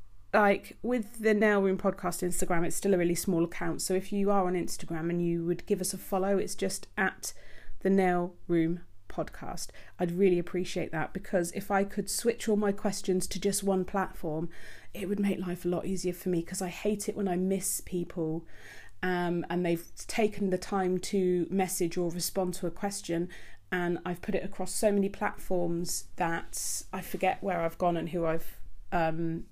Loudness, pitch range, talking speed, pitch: -31 LUFS, 175-195 Hz, 195 wpm, 185 Hz